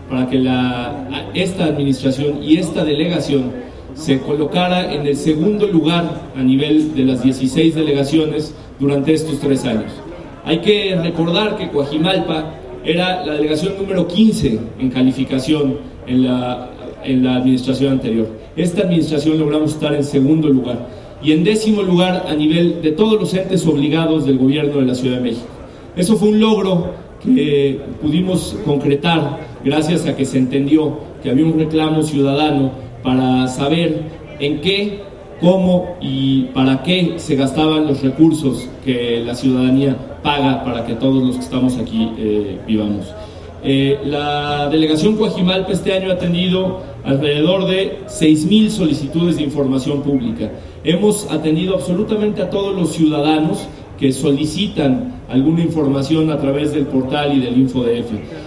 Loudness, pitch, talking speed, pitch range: -16 LUFS, 150 Hz, 145 wpm, 130-165 Hz